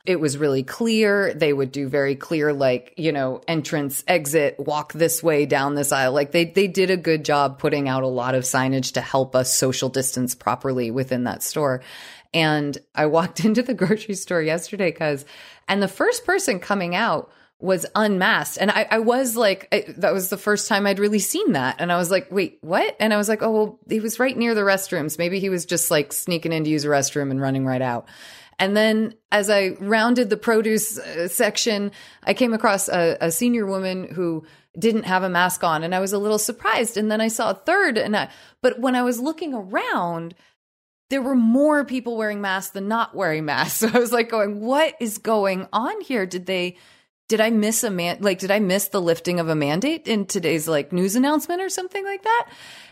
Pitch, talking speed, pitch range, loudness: 190 Hz, 220 wpm, 155-220 Hz, -21 LUFS